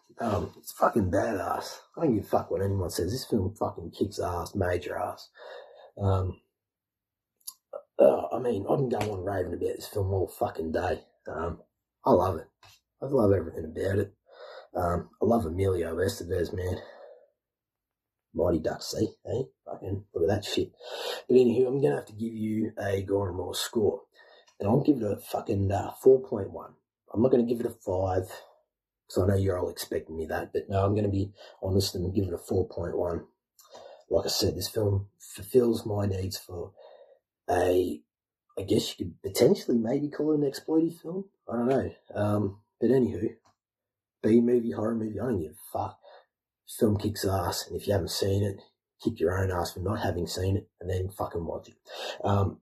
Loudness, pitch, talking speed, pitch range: -29 LUFS, 100 Hz, 190 wpm, 95-120 Hz